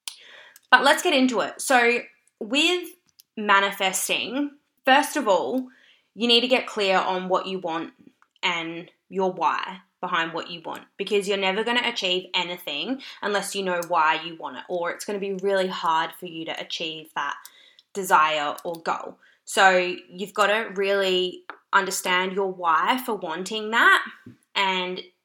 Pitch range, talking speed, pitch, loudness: 180-235 Hz, 160 wpm, 195 Hz, -23 LUFS